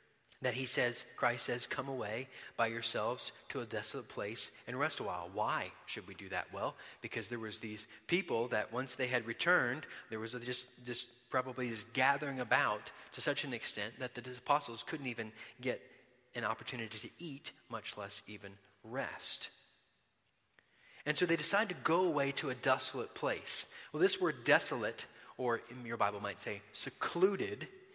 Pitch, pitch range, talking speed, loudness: 125 Hz, 115-140 Hz, 175 wpm, -37 LUFS